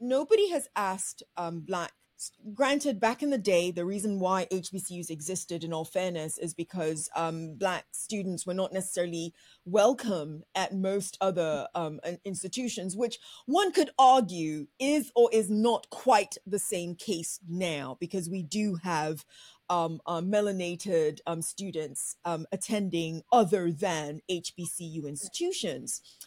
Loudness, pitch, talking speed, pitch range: -30 LUFS, 185 Hz, 135 wpm, 170-210 Hz